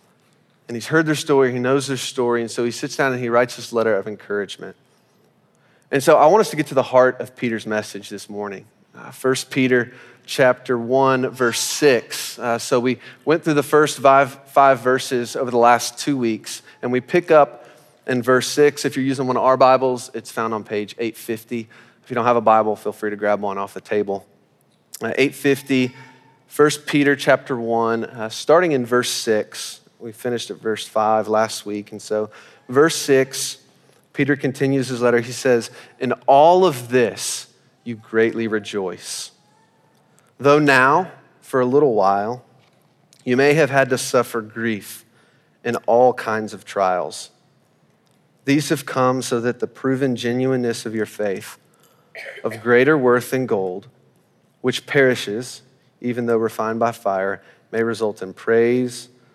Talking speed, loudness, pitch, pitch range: 175 wpm, -19 LUFS, 125 Hz, 115-135 Hz